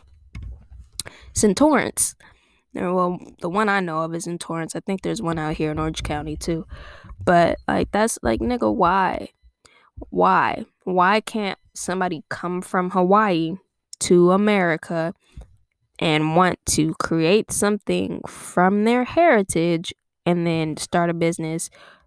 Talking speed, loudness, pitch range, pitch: 135 wpm, -21 LUFS, 155-185 Hz, 170 Hz